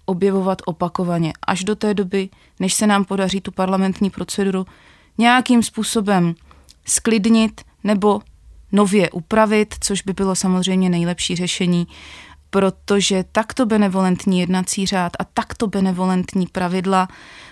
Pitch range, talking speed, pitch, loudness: 185-205 Hz, 115 wpm, 195 Hz, -18 LUFS